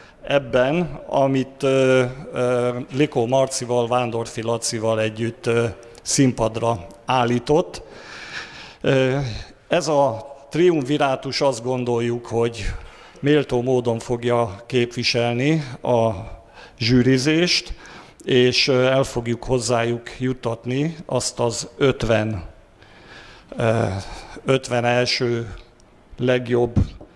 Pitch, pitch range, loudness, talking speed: 125 Hz, 115-130 Hz, -21 LUFS, 85 wpm